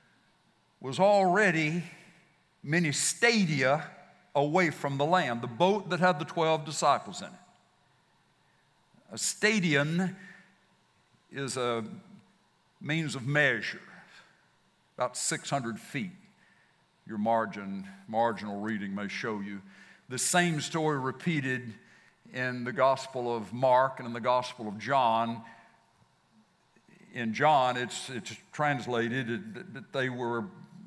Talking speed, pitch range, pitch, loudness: 115 wpm, 120-175 Hz, 140 Hz, -29 LUFS